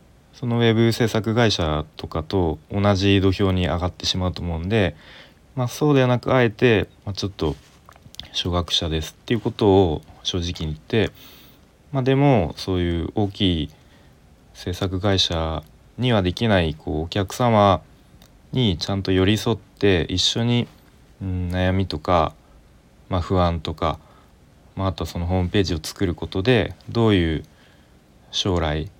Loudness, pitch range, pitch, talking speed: -21 LUFS, 85-105 Hz, 95 Hz, 280 characters per minute